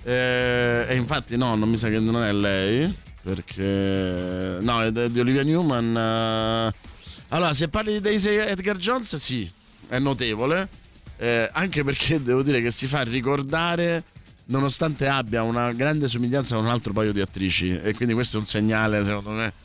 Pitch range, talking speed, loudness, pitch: 110-140 Hz, 170 wpm, -23 LUFS, 120 Hz